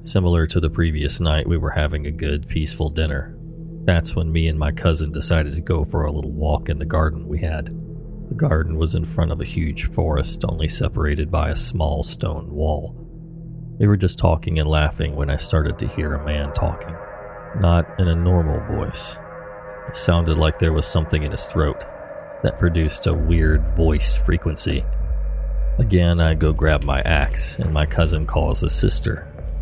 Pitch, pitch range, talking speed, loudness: 80 Hz, 75-85 Hz, 185 wpm, -21 LUFS